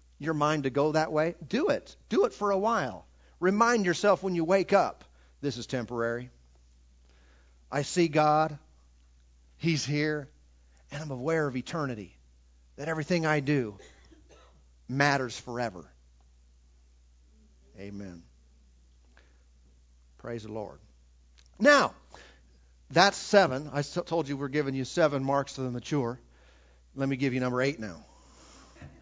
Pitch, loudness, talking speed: 115 Hz, -28 LUFS, 130 wpm